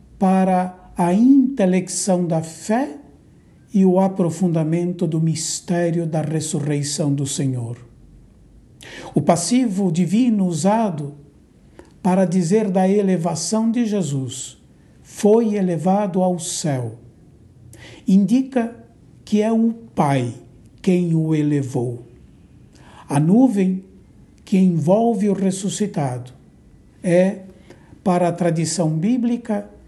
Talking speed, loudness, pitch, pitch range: 95 wpm, -19 LUFS, 180 Hz, 155-200 Hz